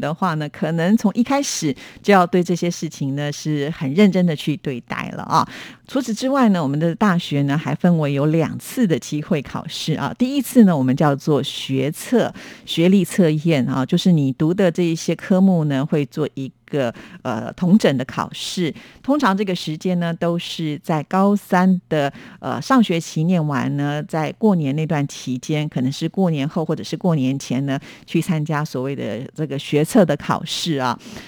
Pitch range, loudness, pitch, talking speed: 145-185 Hz, -19 LUFS, 160 Hz, 270 characters per minute